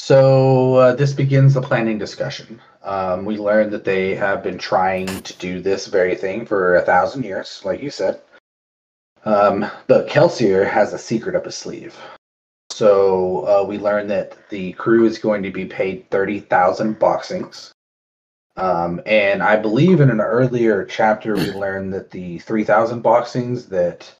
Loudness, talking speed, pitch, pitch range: -17 LUFS, 160 wpm, 105 Hz, 95-125 Hz